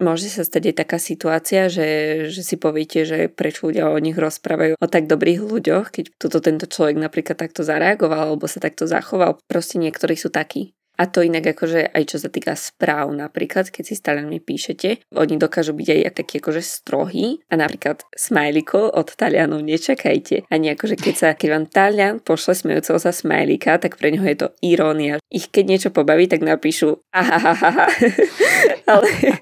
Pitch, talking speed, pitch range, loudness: 165 Hz, 185 wpm, 155-185 Hz, -18 LUFS